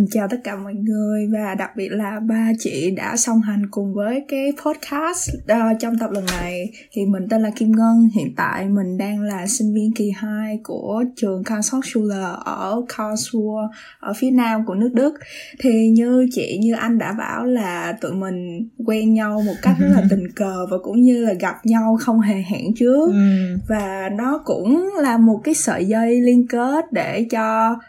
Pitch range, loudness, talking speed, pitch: 200-235 Hz, -19 LUFS, 190 wpm, 220 Hz